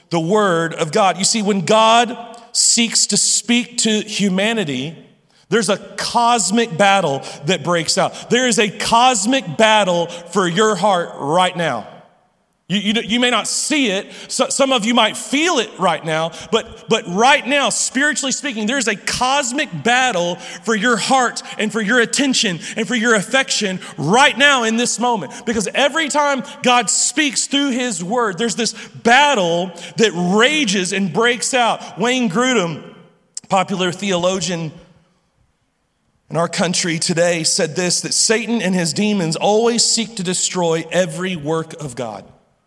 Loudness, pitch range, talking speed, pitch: -16 LUFS, 180-240 Hz, 155 wpm, 215 Hz